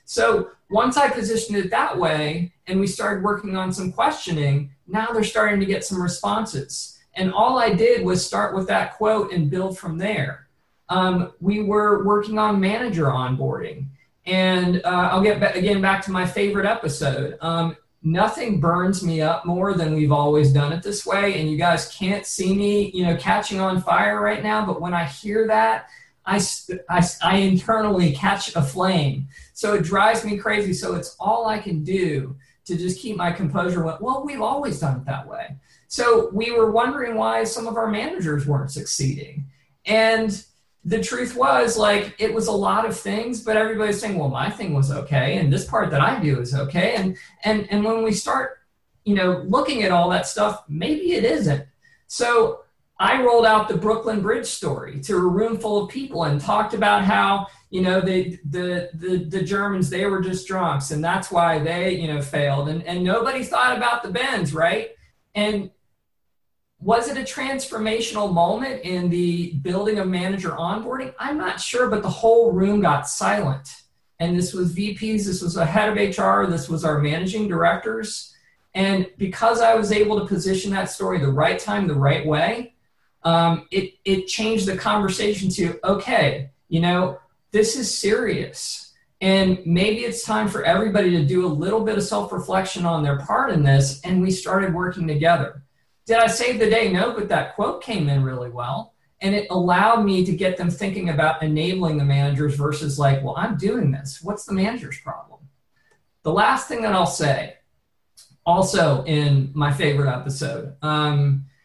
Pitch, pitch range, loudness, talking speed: 185 Hz, 160-215 Hz, -21 LUFS, 185 wpm